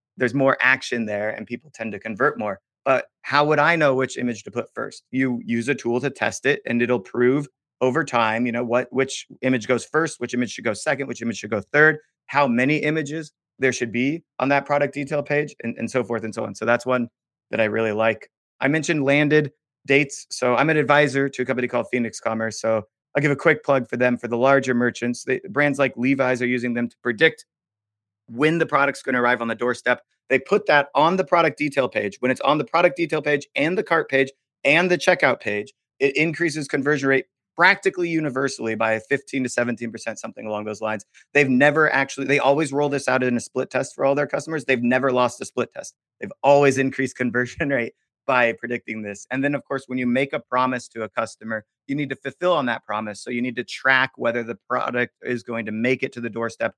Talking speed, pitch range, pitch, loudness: 235 wpm, 120-145 Hz, 130 Hz, -22 LUFS